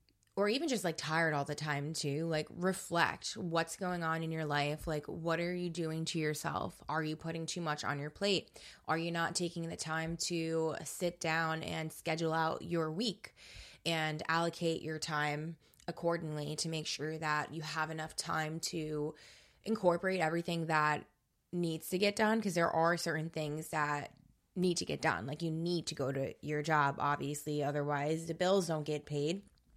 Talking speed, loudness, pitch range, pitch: 185 wpm, -36 LUFS, 150-170 Hz, 160 Hz